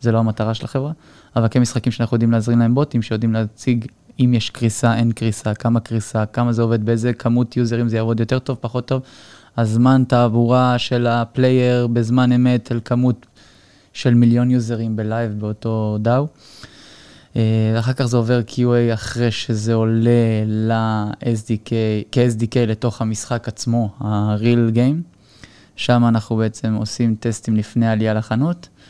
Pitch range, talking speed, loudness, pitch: 110-125 Hz, 145 wpm, -18 LUFS, 115 Hz